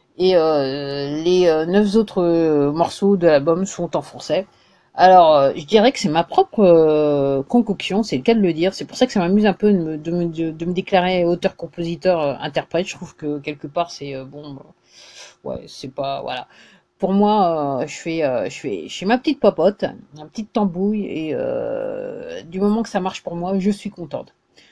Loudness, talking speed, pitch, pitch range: -18 LUFS, 190 wpm, 180 Hz, 155-205 Hz